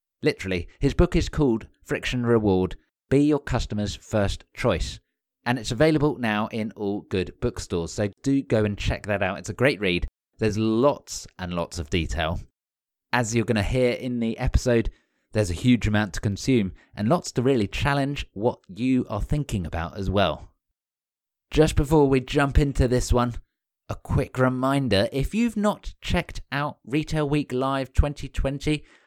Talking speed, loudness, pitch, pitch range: 170 wpm, -25 LUFS, 115 Hz, 95-135 Hz